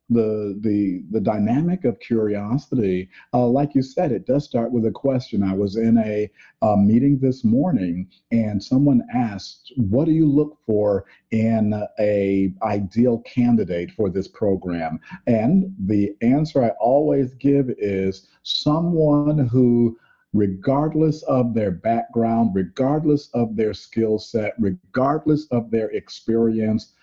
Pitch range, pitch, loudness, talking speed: 105-135 Hz, 115 Hz, -21 LUFS, 135 wpm